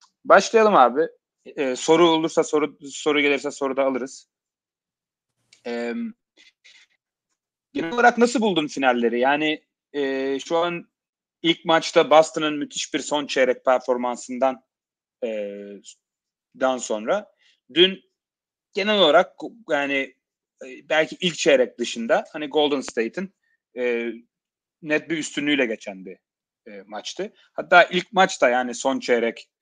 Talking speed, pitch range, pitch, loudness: 115 wpm, 125-170 Hz, 145 Hz, -21 LUFS